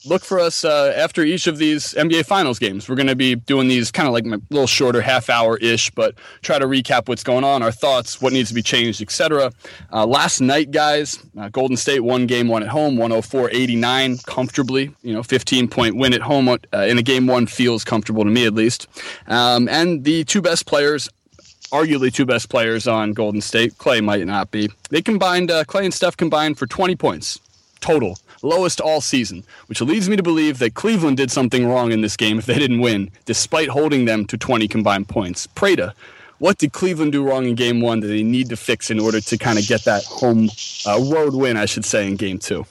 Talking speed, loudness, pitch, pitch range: 220 wpm, -18 LUFS, 125 Hz, 115-150 Hz